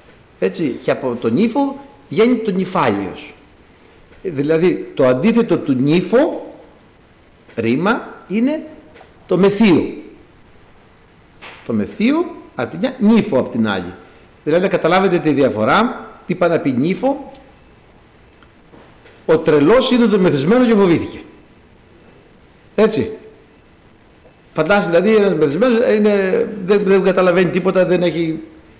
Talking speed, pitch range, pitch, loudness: 115 wpm, 160-230 Hz, 190 Hz, -16 LUFS